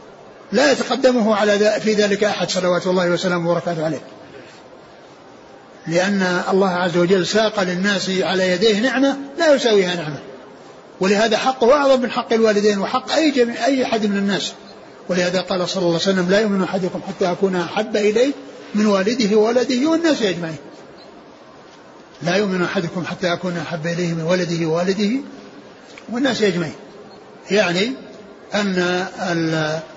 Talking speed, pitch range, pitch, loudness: 135 wpm, 180-220 Hz, 195 Hz, -18 LUFS